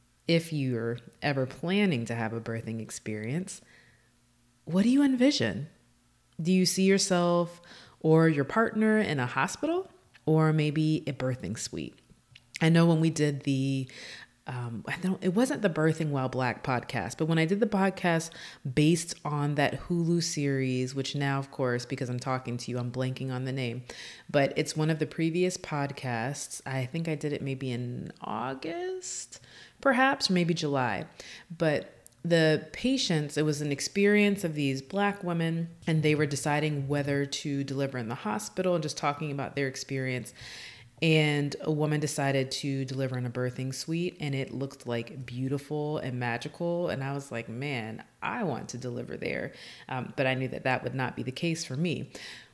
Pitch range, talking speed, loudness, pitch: 130-165 Hz, 175 wpm, -29 LUFS, 145 Hz